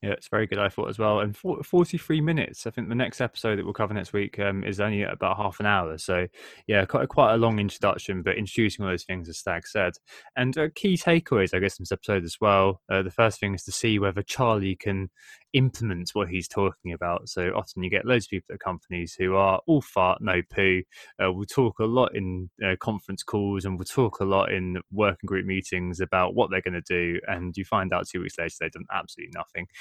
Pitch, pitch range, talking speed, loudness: 100 Hz, 95-110 Hz, 245 wpm, -26 LUFS